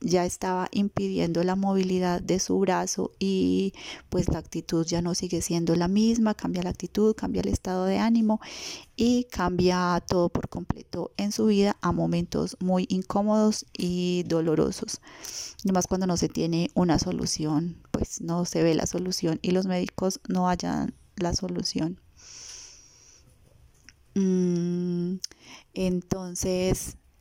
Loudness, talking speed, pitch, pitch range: -27 LUFS, 135 wpm, 180 Hz, 170-195 Hz